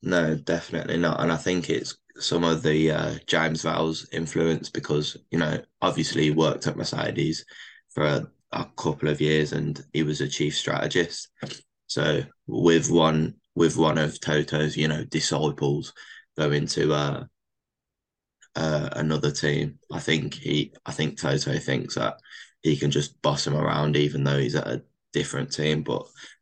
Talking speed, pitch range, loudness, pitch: 165 wpm, 75-80 Hz, -25 LUFS, 75 Hz